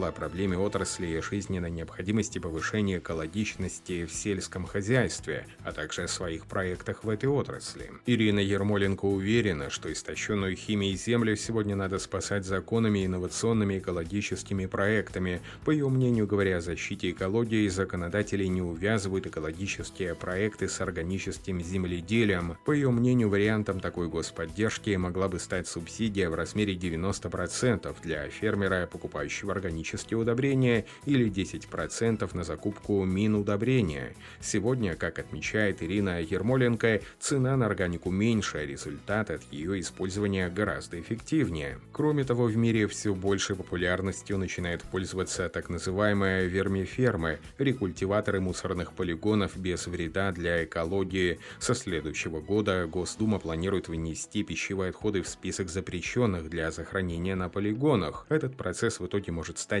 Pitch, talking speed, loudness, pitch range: 95 Hz, 130 wpm, -30 LUFS, 90-105 Hz